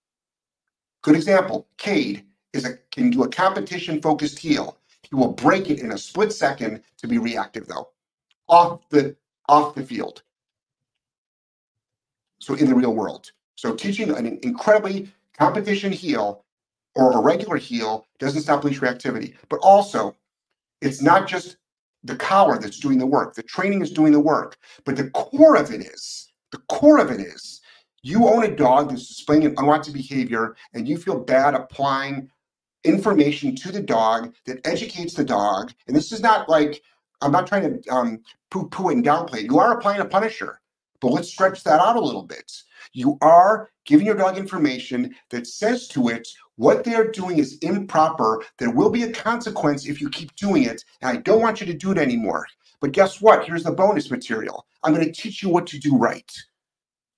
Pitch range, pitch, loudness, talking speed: 140-215 Hz, 165 Hz, -20 LUFS, 185 wpm